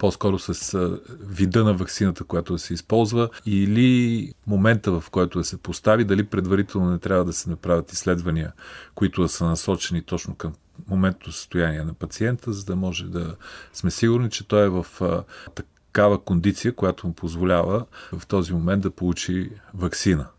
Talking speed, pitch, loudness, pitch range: 160 wpm, 95 Hz, -23 LUFS, 85-105 Hz